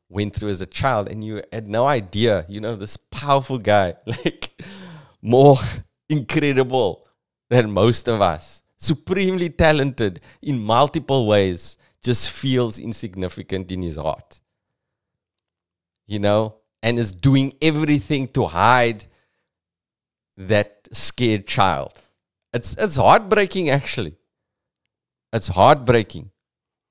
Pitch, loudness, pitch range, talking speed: 115 Hz, -20 LUFS, 100-135 Hz, 110 wpm